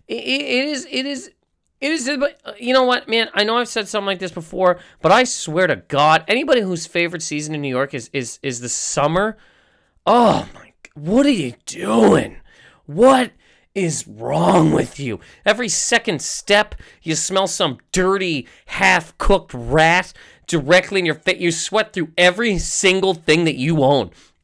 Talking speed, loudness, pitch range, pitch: 170 wpm, -18 LUFS, 155-220 Hz, 185 Hz